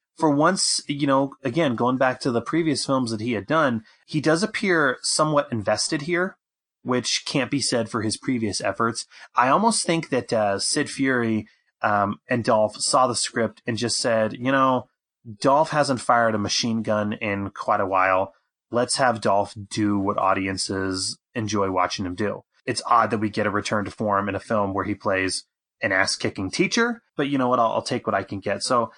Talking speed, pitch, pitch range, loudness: 200 wpm, 115 Hz, 105-140 Hz, -23 LUFS